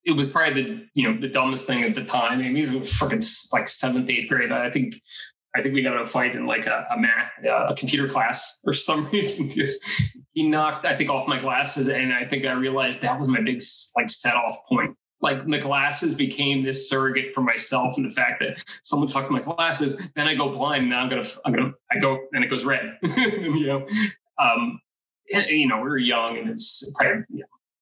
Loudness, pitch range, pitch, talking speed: -23 LUFS, 135-200 Hz, 140 Hz, 240 wpm